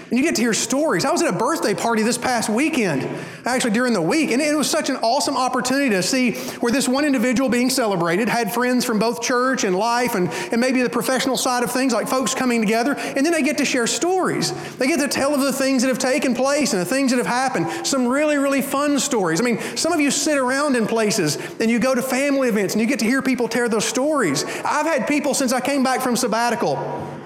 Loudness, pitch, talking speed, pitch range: -19 LUFS, 255 Hz, 255 wpm, 235-275 Hz